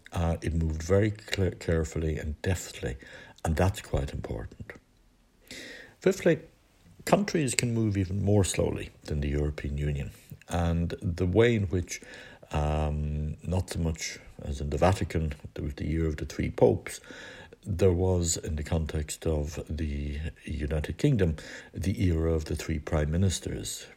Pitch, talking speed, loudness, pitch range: 85 Hz, 150 wpm, -29 LUFS, 75-95 Hz